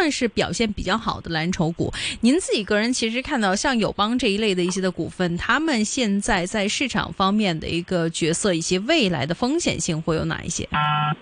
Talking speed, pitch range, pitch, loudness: 315 characters per minute, 170-235 Hz, 200 Hz, -22 LUFS